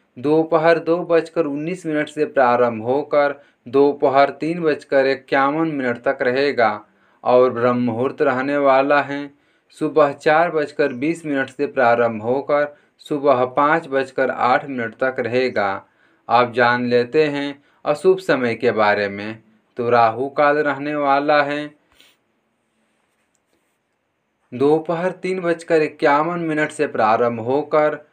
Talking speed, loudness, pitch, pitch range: 125 wpm, -18 LUFS, 140 Hz, 125-150 Hz